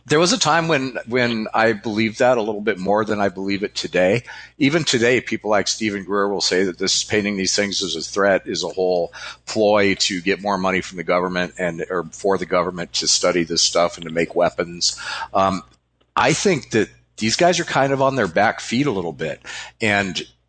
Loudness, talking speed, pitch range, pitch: -19 LUFS, 220 wpm, 90-110 Hz, 100 Hz